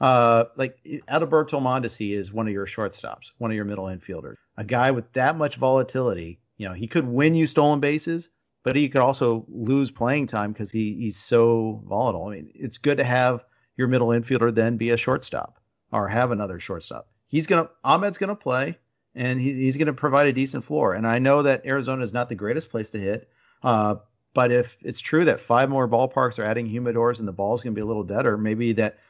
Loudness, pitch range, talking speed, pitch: -23 LUFS, 110-135 Hz, 225 wpm, 120 Hz